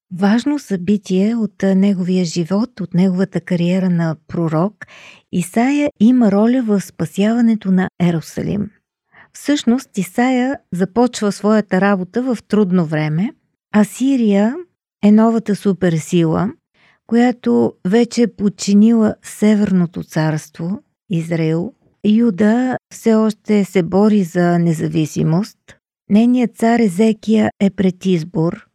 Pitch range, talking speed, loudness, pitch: 180-225 Hz, 105 wpm, -16 LUFS, 205 Hz